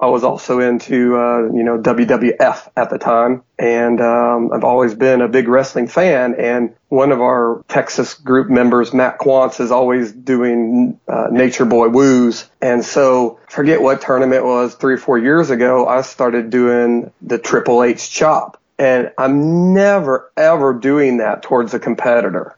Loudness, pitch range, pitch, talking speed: -14 LUFS, 120-130 Hz, 125 Hz, 170 wpm